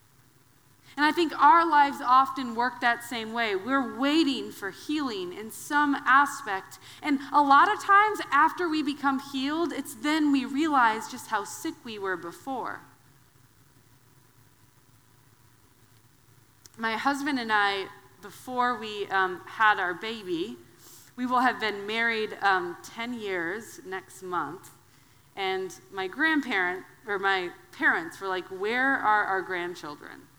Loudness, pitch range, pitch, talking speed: -26 LUFS, 175-280 Hz, 220 Hz, 135 wpm